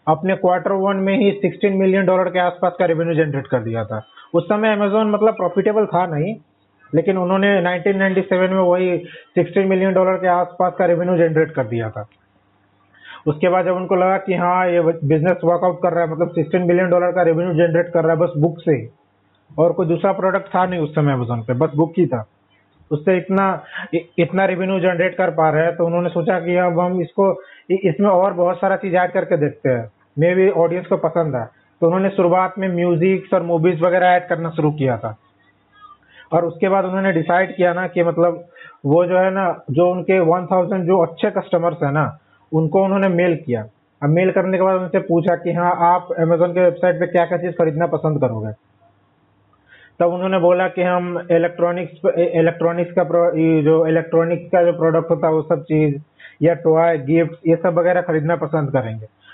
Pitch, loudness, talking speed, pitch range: 175 Hz, -17 LUFS, 195 wpm, 160-185 Hz